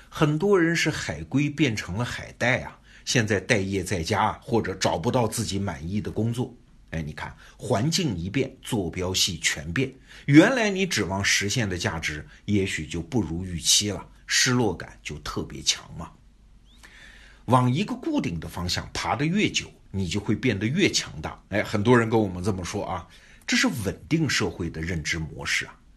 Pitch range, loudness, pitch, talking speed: 90-130 Hz, -25 LUFS, 105 Hz, 255 characters per minute